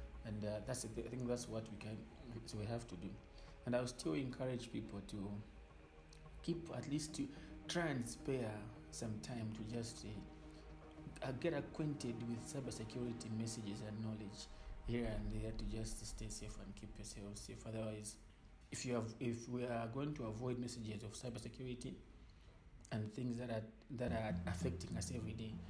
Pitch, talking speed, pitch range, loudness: 110 Hz, 175 wpm, 105-125 Hz, -46 LUFS